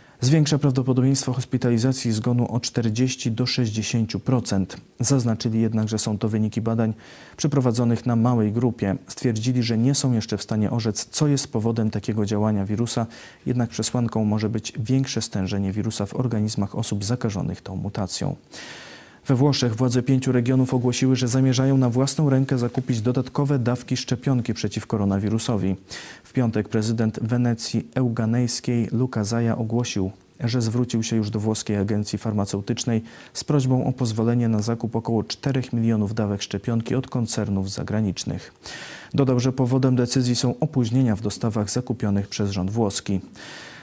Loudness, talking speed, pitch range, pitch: -23 LUFS, 145 wpm, 110-125 Hz, 115 Hz